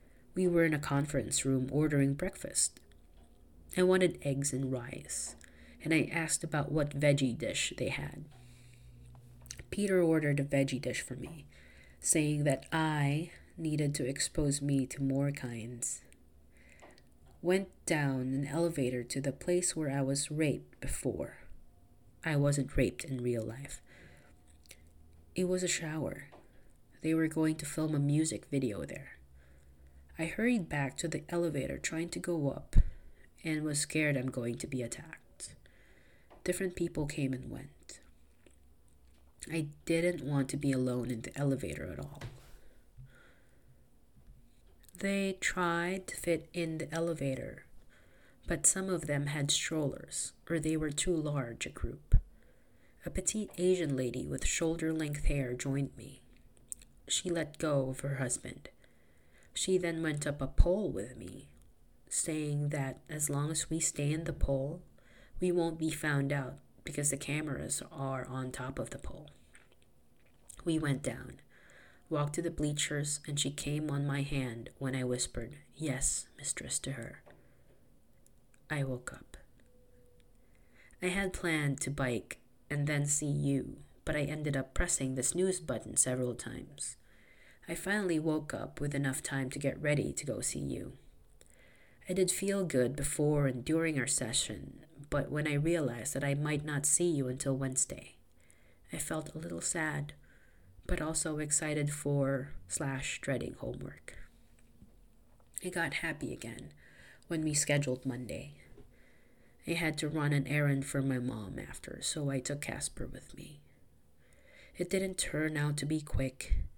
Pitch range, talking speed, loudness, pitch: 125-155 Hz, 150 wpm, -34 LUFS, 140 Hz